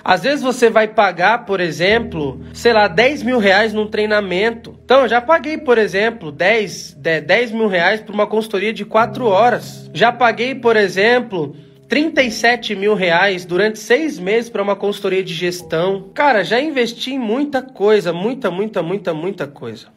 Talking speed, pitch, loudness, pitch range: 170 wpm, 215 Hz, -16 LUFS, 190-235 Hz